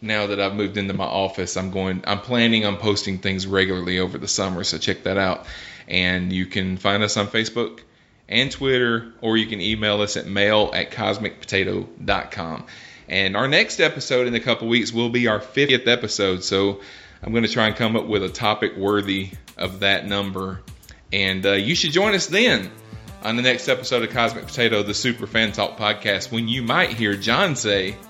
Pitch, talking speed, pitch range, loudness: 105 Hz, 200 wpm, 95-115 Hz, -21 LUFS